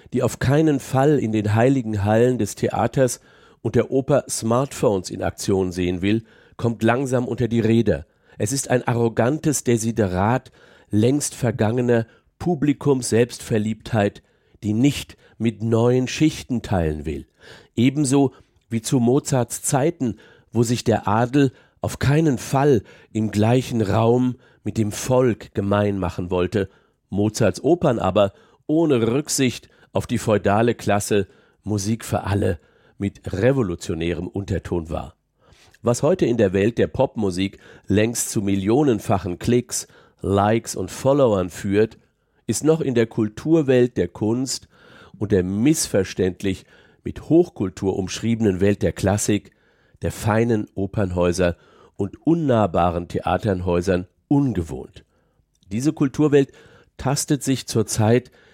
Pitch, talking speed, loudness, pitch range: 115 Hz, 120 wpm, -21 LUFS, 100-125 Hz